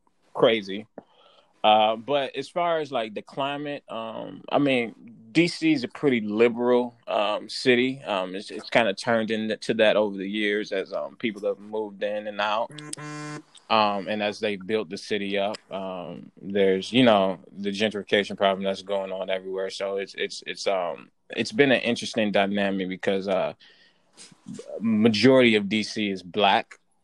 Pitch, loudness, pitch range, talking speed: 105 Hz, -25 LUFS, 100-130 Hz, 165 wpm